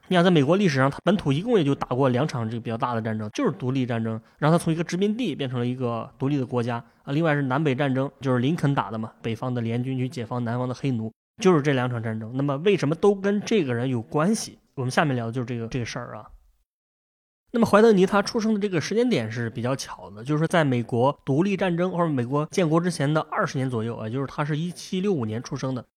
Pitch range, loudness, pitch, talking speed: 120-170 Hz, -24 LUFS, 135 Hz, 395 characters per minute